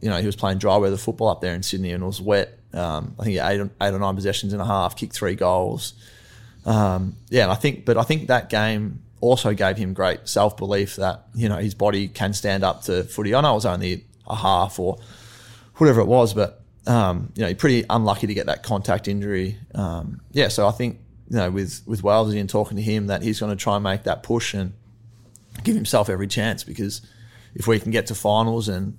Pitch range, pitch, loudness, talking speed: 100-115 Hz, 105 Hz, -22 LUFS, 240 wpm